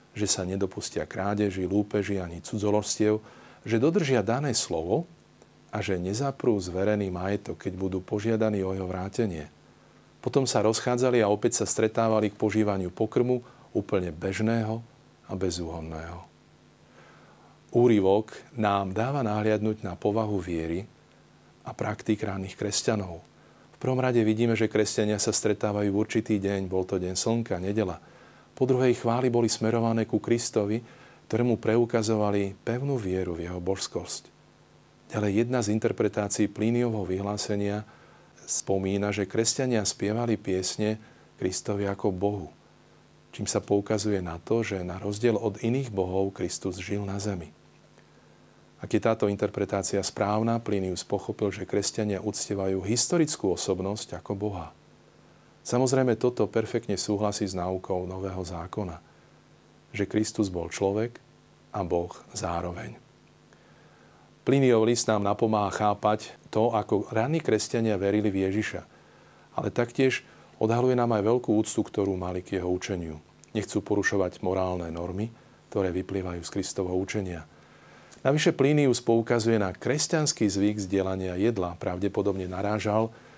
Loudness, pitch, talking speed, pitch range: -27 LUFS, 105 Hz, 125 wpm, 95-115 Hz